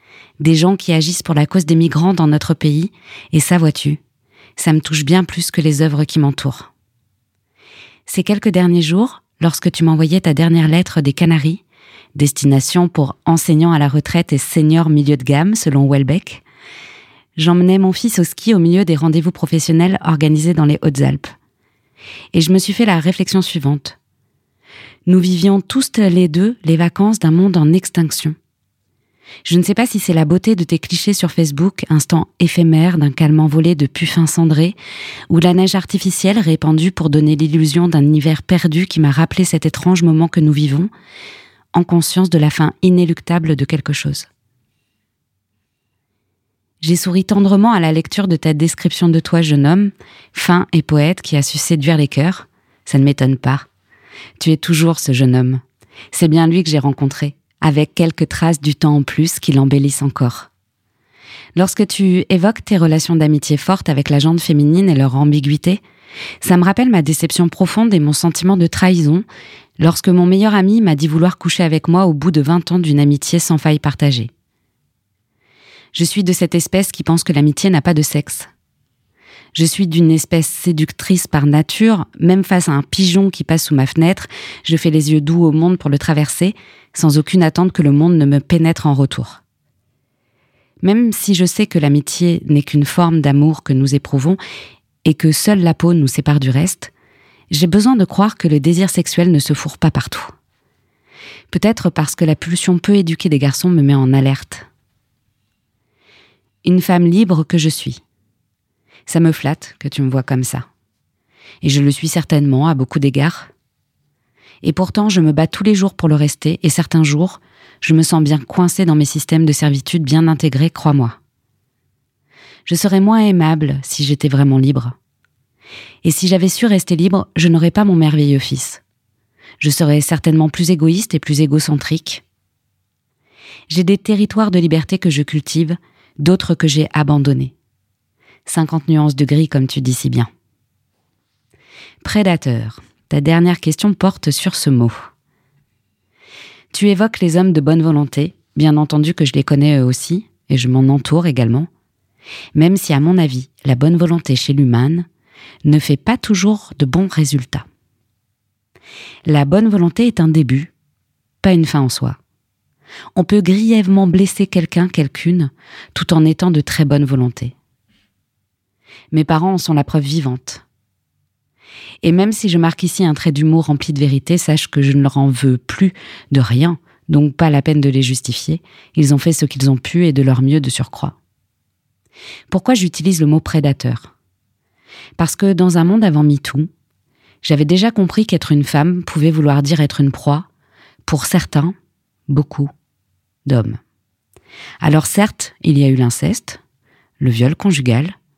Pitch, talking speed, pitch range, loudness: 155 Hz, 175 wpm, 140-175 Hz, -14 LUFS